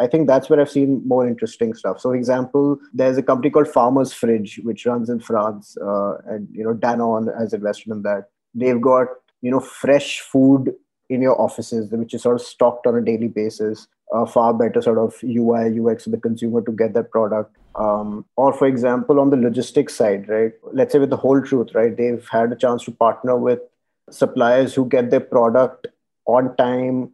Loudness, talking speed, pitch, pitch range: -19 LUFS, 210 wpm, 120 Hz, 115-130 Hz